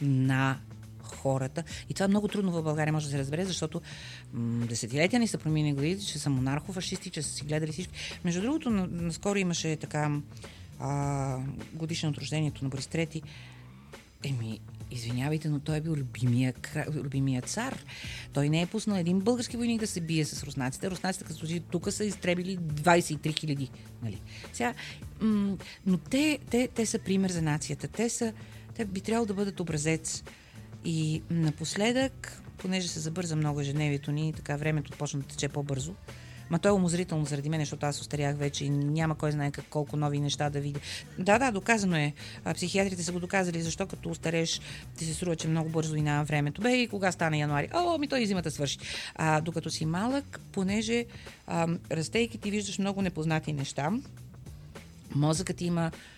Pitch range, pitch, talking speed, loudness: 140-185 Hz, 155 Hz, 175 wpm, -31 LUFS